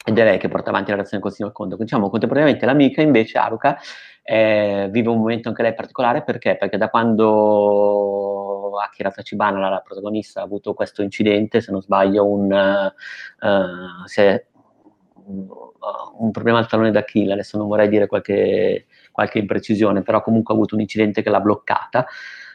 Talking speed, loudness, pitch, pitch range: 170 wpm, -18 LUFS, 105 Hz, 100-110 Hz